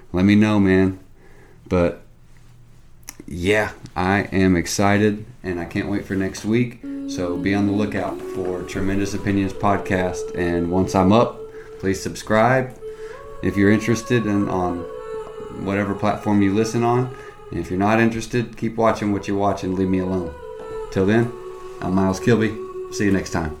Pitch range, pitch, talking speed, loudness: 95-120 Hz, 100 Hz, 160 wpm, -21 LUFS